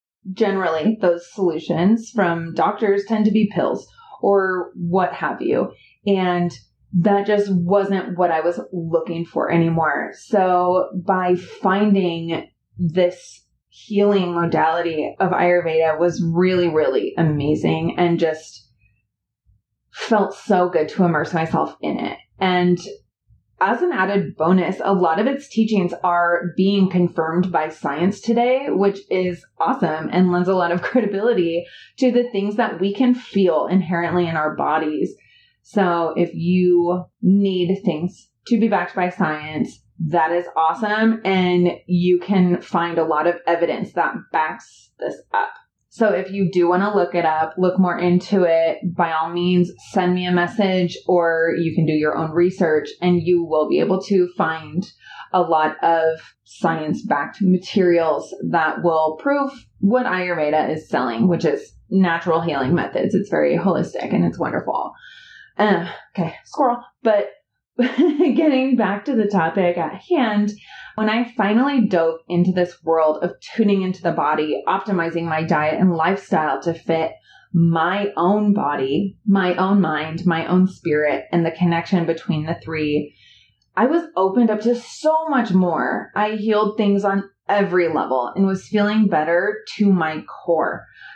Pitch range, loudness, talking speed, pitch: 165-200 Hz, -19 LUFS, 150 wpm, 180 Hz